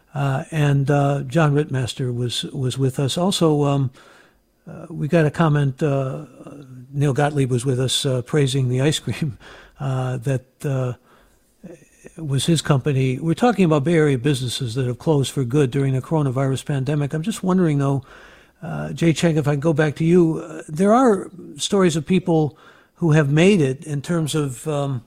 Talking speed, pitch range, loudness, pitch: 180 wpm, 135-160 Hz, -20 LUFS, 145 Hz